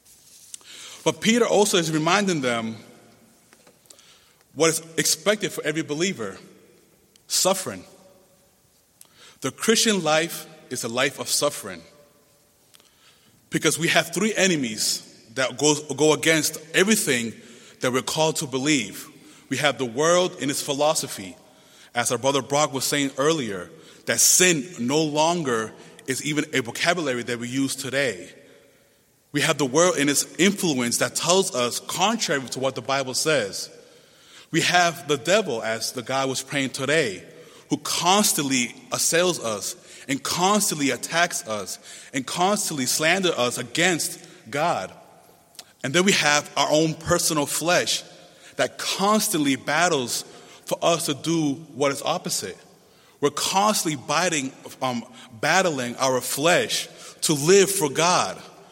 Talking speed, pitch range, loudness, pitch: 135 wpm, 135-175 Hz, -22 LUFS, 155 Hz